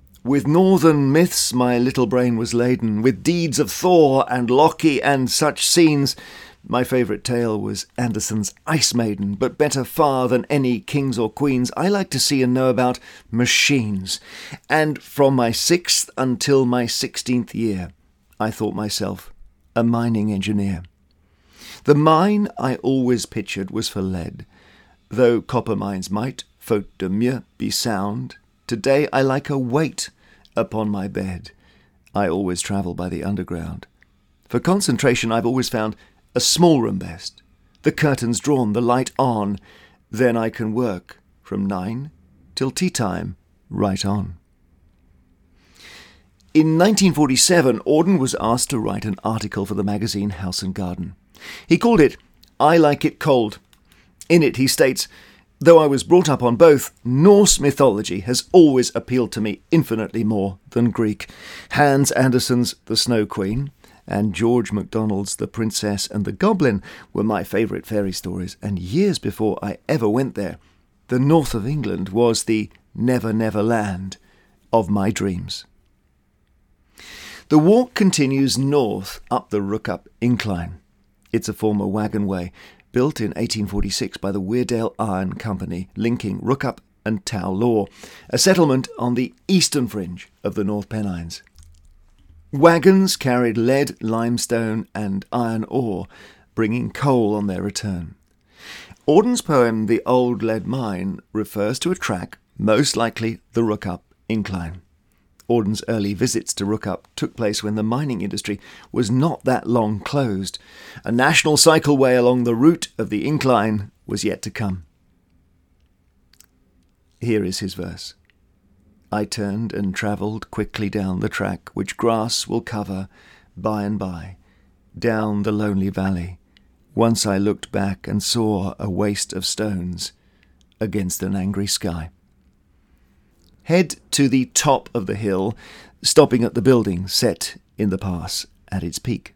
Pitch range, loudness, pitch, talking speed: 95-125 Hz, -20 LUFS, 110 Hz, 145 wpm